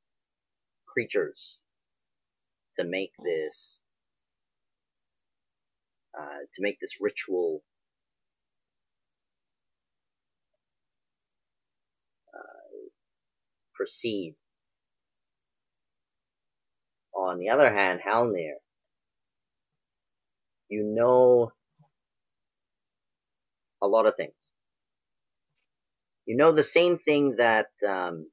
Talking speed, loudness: 60 wpm, -26 LUFS